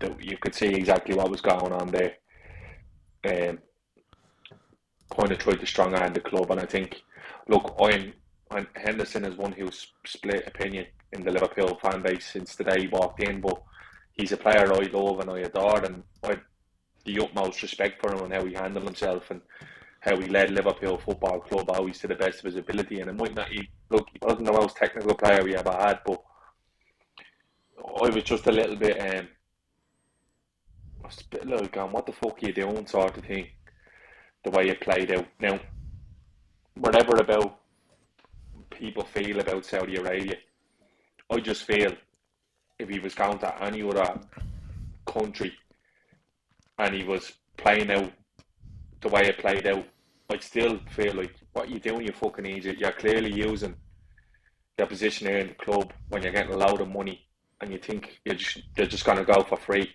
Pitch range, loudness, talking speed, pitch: 95-100 Hz, -27 LUFS, 180 wpm, 95 Hz